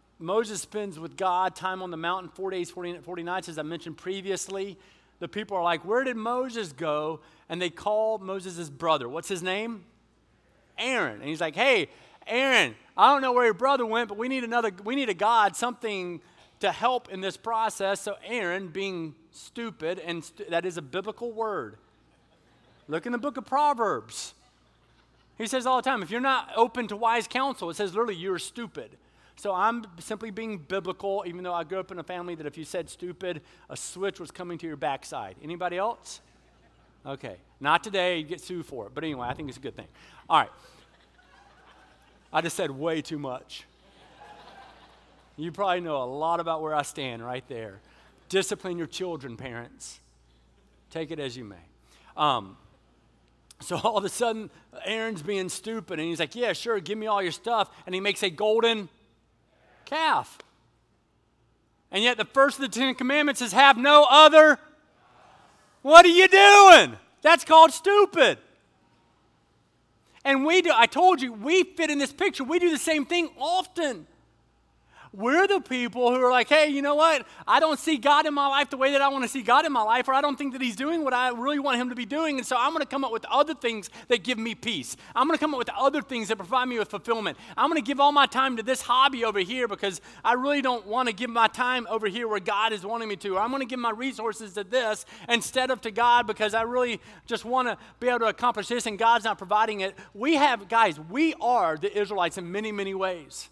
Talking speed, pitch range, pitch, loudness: 210 wpm, 180-260 Hz, 220 Hz, -24 LUFS